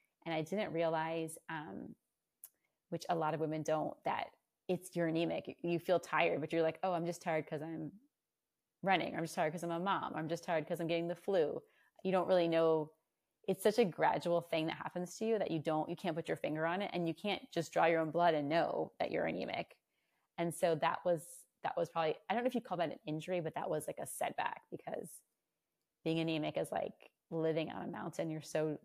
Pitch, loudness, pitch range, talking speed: 165 Hz, -37 LUFS, 160-175 Hz, 235 wpm